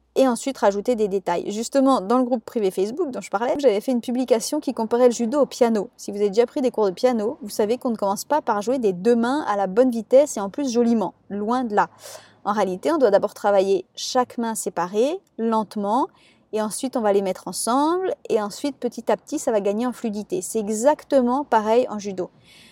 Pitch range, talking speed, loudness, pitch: 205-255 Hz, 230 wpm, -22 LUFS, 230 Hz